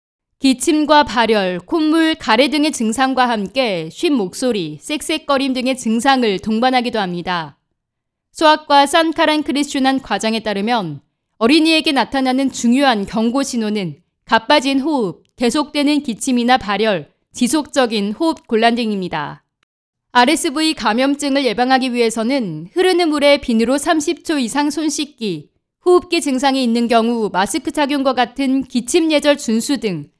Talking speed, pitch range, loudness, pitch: 300 characters per minute, 225-295 Hz, -16 LUFS, 260 Hz